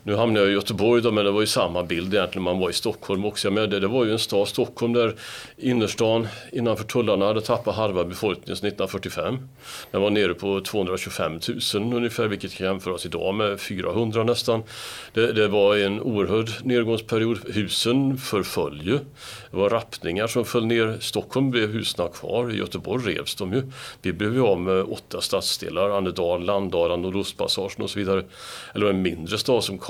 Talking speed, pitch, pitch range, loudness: 185 wpm, 105 Hz, 100-115 Hz, -24 LUFS